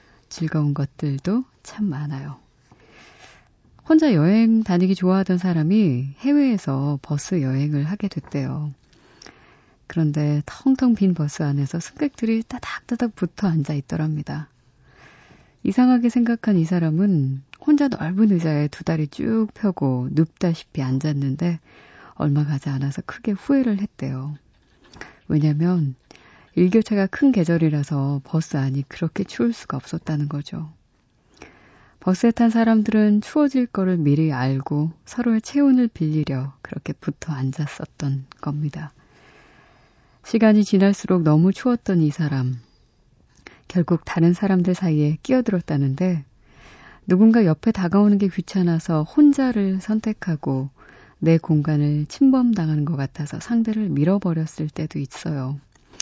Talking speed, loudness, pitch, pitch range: 280 characters per minute, -21 LUFS, 165 Hz, 145-205 Hz